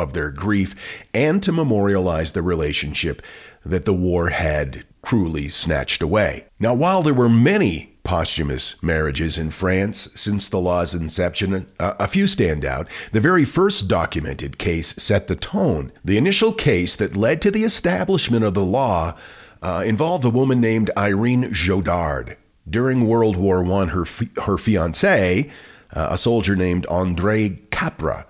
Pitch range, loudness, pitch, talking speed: 85-115 Hz, -19 LUFS, 95 Hz, 155 wpm